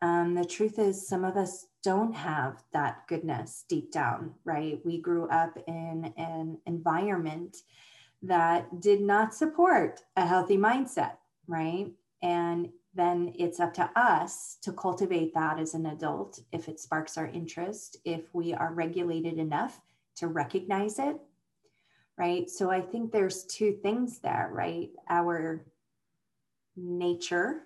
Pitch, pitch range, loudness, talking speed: 175 Hz, 165-195 Hz, -30 LUFS, 140 wpm